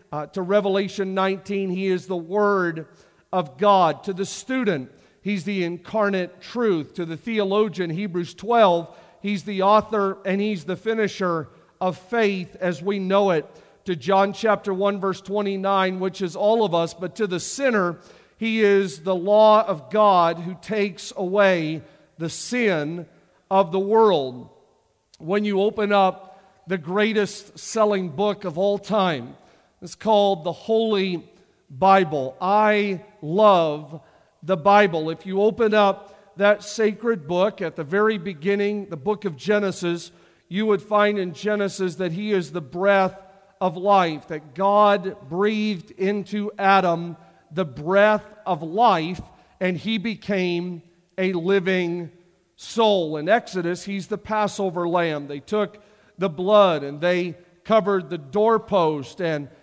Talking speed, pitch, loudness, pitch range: 145 wpm, 195 Hz, -22 LUFS, 175-205 Hz